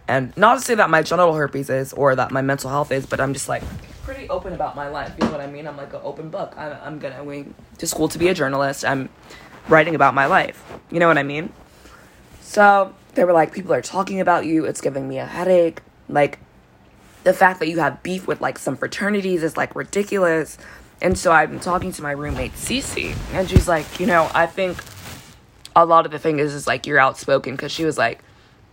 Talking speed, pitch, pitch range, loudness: 230 wpm, 155 Hz, 140-175 Hz, -19 LUFS